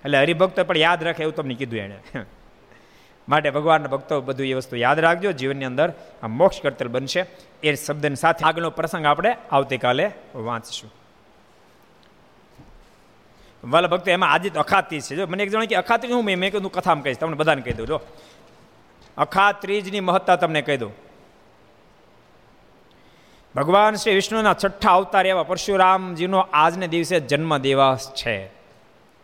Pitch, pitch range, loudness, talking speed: 155 Hz, 135-185 Hz, -21 LUFS, 145 wpm